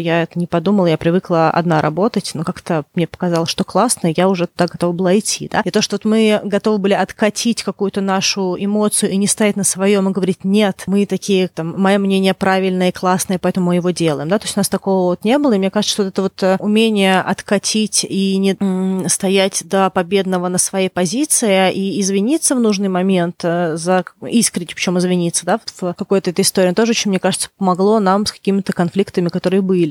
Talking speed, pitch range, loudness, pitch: 205 wpm, 180-200 Hz, -16 LUFS, 190 Hz